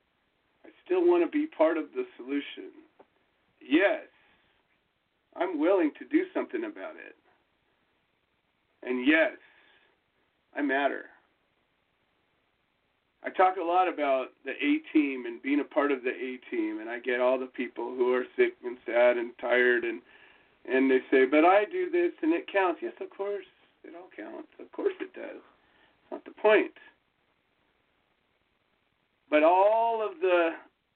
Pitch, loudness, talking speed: 320 Hz, -27 LUFS, 150 wpm